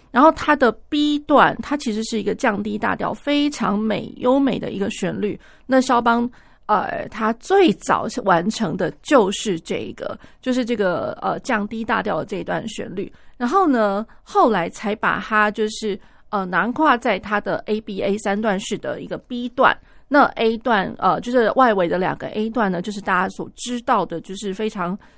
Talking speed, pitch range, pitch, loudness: 260 characters per minute, 205-250 Hz, 220 Hz, -20 LUFS